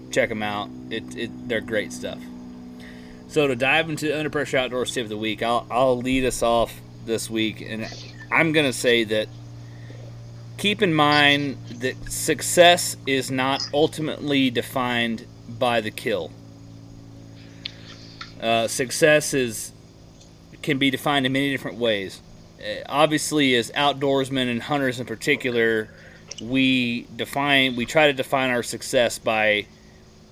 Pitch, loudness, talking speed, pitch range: 125 Hz, -22 LUFS, 140 wpm, 115-140 Hz